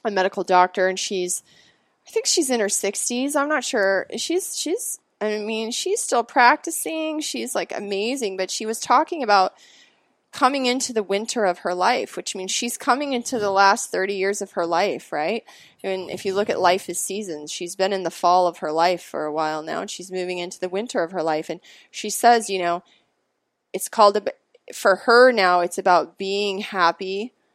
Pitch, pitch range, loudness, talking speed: 195 Hz, 180-240 Hz, -21 LUFS, 205 wpm